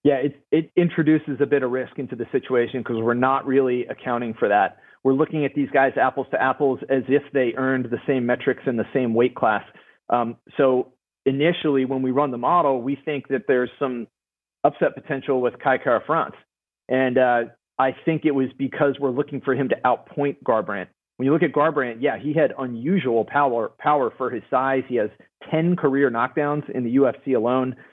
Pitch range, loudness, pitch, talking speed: 125-145 Hz, -22 LUFS, 135 Hz, 200 wpm